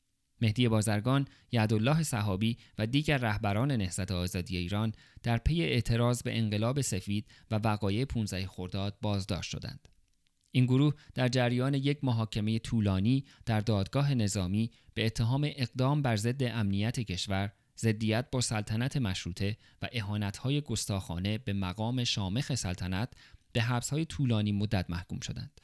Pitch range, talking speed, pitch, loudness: 100-125 Hz, 130 wpm, 110 Hz, -31 LUFS